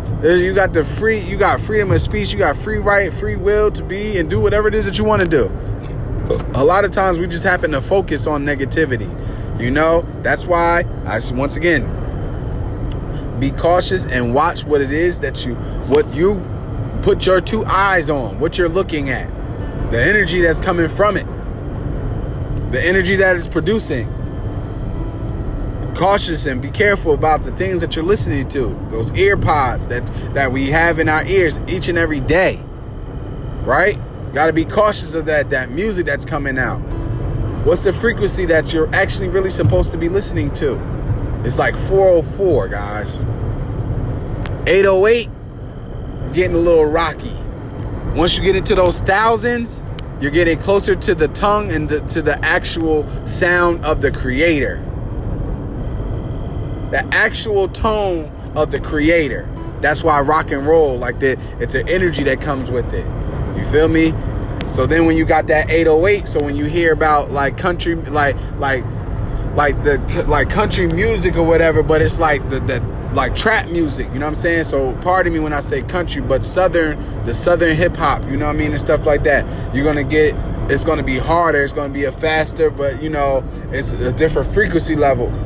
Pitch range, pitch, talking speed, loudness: 120-165 Hz, 140 Hz, 180 wpm, -17 LUFS